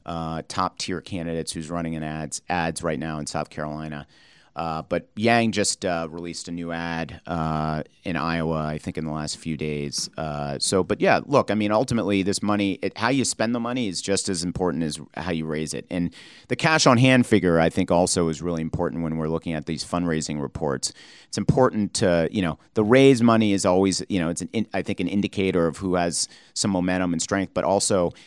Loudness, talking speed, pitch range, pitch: -24 LUFS, 215 wpm, 80-100 Hz, 85 Hz